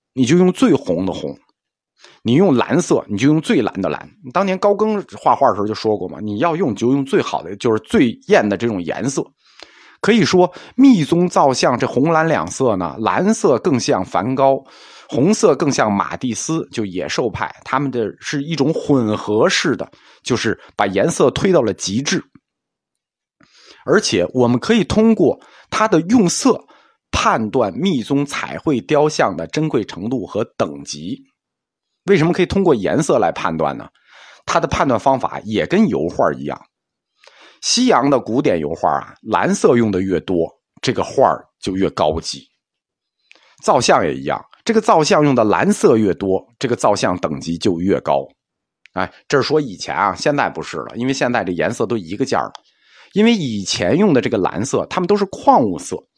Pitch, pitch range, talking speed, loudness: 155 Hz, 125-200 Hz, 255 characters per minute, -17 LUFS